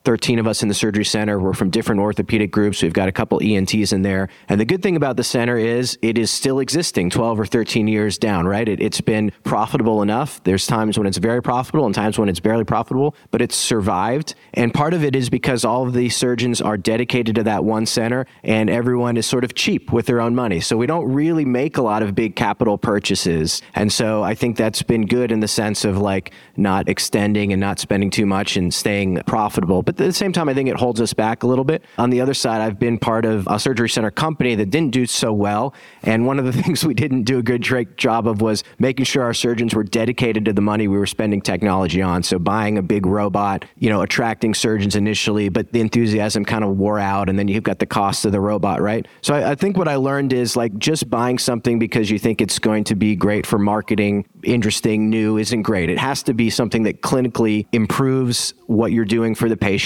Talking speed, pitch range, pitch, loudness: 240 wpm, 105-125 Hz, 115 Hz, -18 LUFS